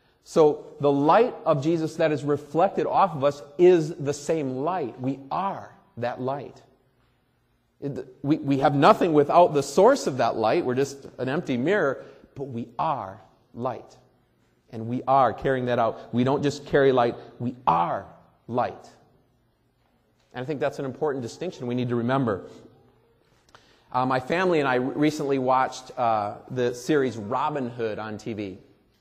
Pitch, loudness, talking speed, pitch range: 135 Hz, -24 LUFS, 155 wpm, 125-145 Hz